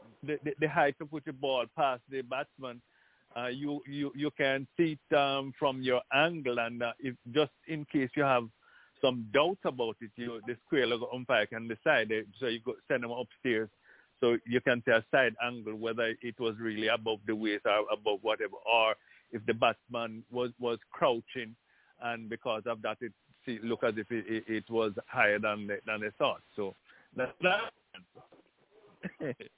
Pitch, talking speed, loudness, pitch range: 120 Hz, 190 wpm, -32 LUFS, 115-135 Hz